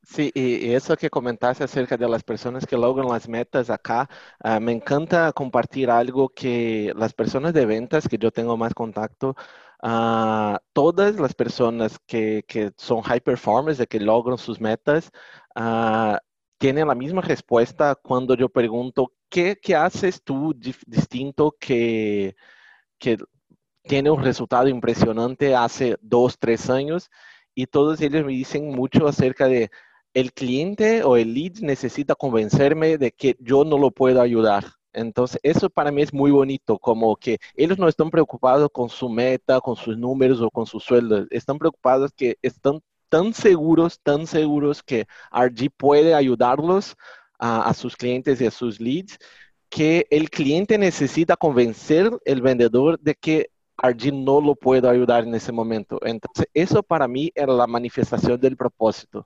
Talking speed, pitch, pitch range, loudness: 160 wpm, 130 Hz, 115-145 Hz, -21 LUFS